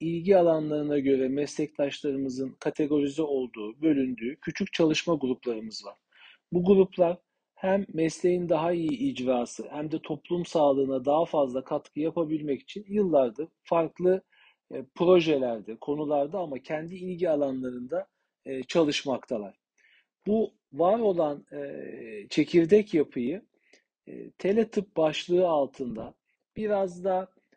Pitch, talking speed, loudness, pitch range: 155 Hz, 100 wpm, -27 LUFS, 135-180 Hz